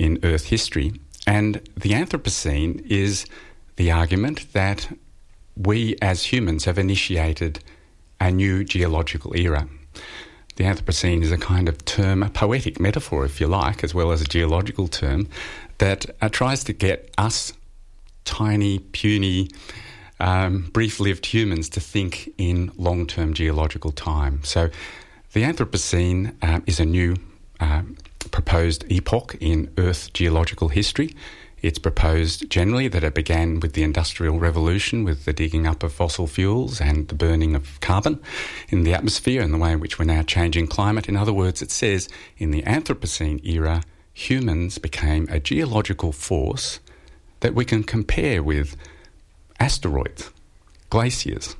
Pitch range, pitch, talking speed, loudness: 80-100 Hz, 85 Hz, 145 wpm, -22 LUFS